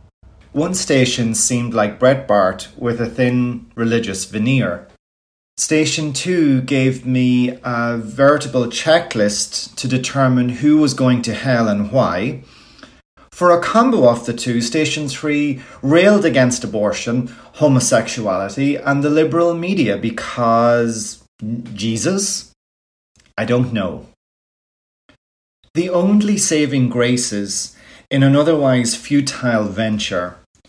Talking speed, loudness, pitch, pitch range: 110 wpm, -16 LUFS, 125 Hz, 115-145 Hz